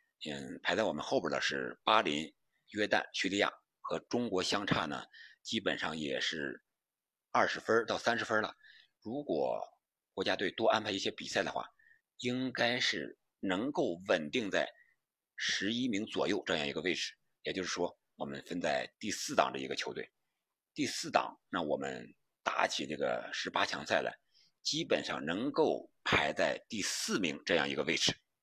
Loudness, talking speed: -34 LUFS, 245 characters per minute